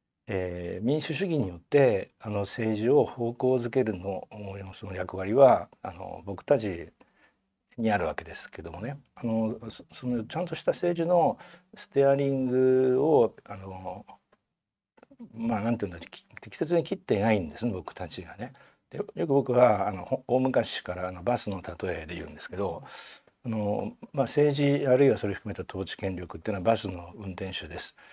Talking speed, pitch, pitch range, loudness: 295 characters per minute, 115 Hz, 95-140 Hz, -28 LUFS